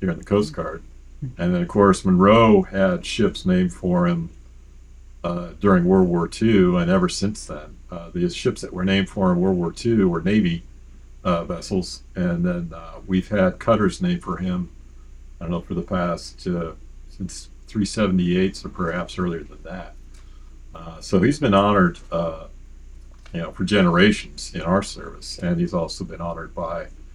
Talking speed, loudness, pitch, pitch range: 180 wpm, -21 LUFS, 90 Hz, 70-100 Hz